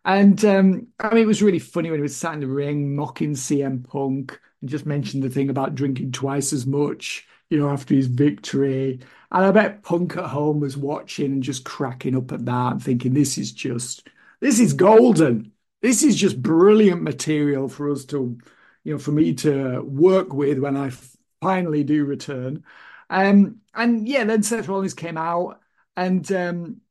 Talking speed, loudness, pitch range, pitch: 190 wpm, -21 LUFS, 140-190 Hz, 145 Hz